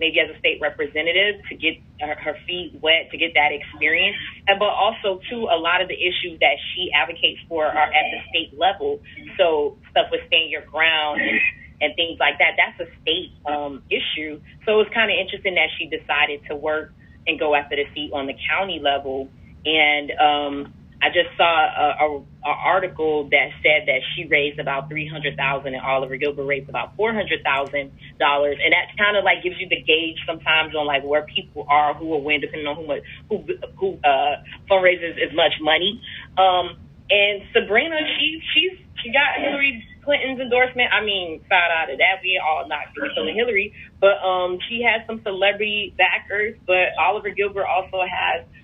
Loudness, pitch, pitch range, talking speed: -20 LUFS, 170 Hz, 150-205 Hz, 190 wpm